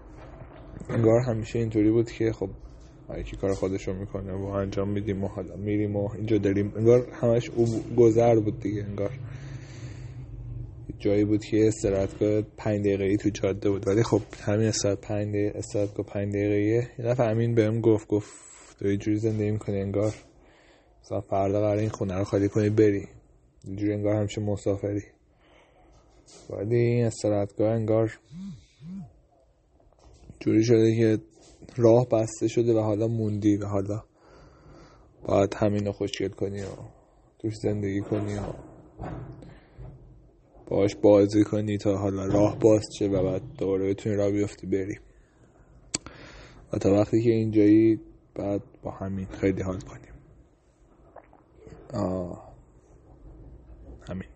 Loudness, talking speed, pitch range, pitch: -26 LUFS, 135 wpm, 100-115 Hz, 105 Hz